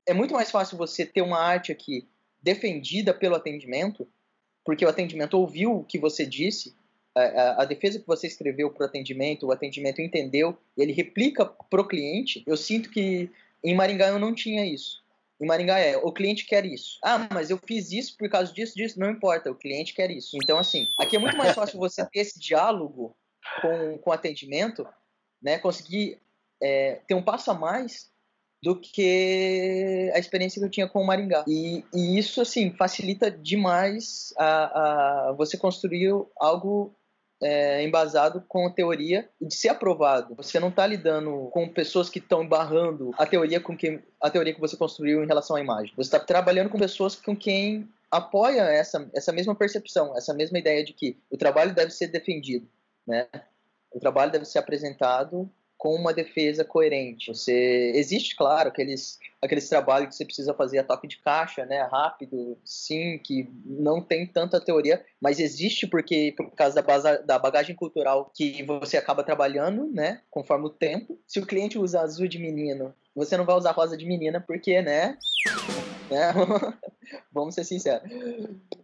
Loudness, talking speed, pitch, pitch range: -25 LUFS, 180 wpm, 170 Hz, 150-195 Hz